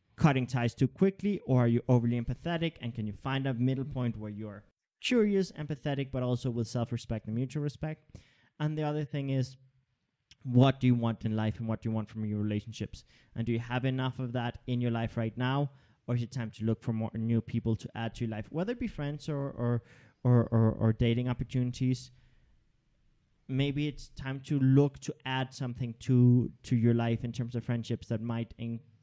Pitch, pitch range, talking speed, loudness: 125 Hz, 115-135 Hz, 215 wpm, -32 LUFS